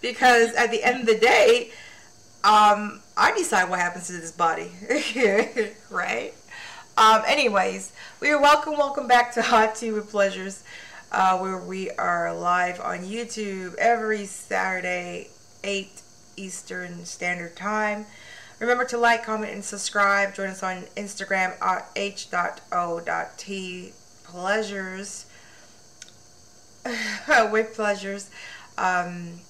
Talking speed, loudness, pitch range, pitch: 115 wpm, -23 LUFS, 185-225 Hz, 200 Hz